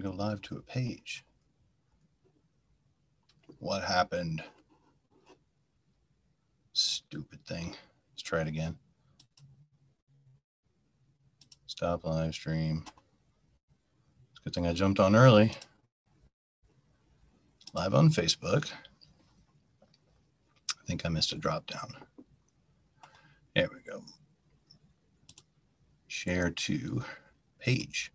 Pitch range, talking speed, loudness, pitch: 85-135 Hz, 85 wpm, -30 LUFS, 120 Hz